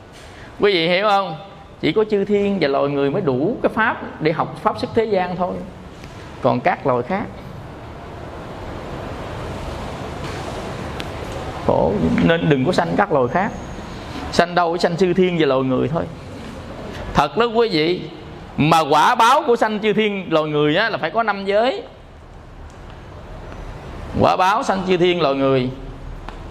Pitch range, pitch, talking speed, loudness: 155-205 Hz, 180 Hz, 160 wpm, -19 LUFS